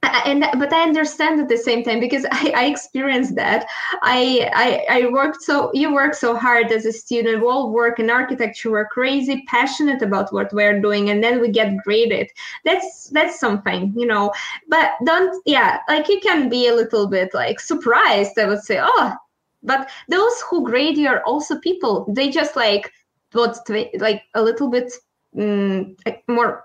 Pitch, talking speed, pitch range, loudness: 245 Hz, 180 wpm, 225-290 Hz, -18 LUFS